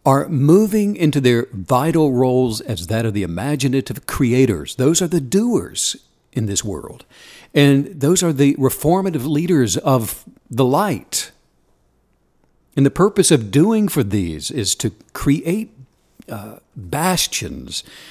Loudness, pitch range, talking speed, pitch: -17 LUFS, 120-160 Hz, 135 wpm, 140 Hz